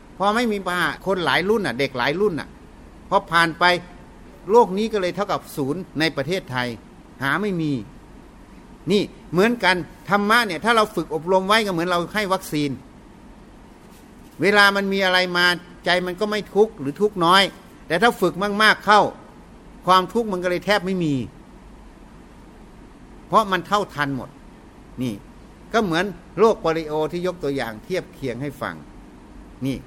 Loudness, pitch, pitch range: -20 LUFS, 180 Hz, 160-205 Hz